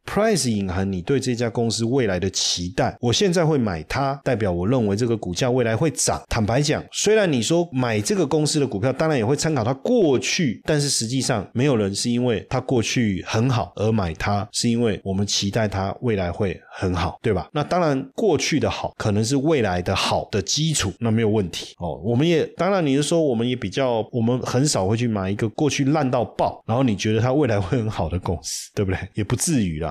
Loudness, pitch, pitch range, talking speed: -21 LUFS, 115 Hz, 100-135 Hz, 335 characters per minute